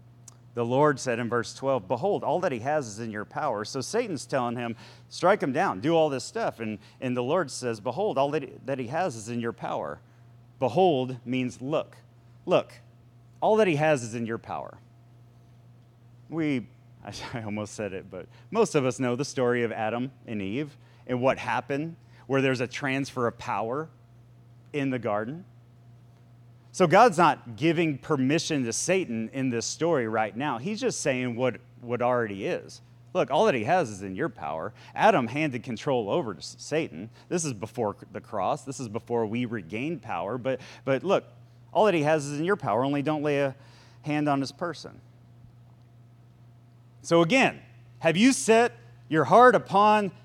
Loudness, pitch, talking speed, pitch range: -27 LUFS, 120 Hz, 180 wpm, 120-145 Hz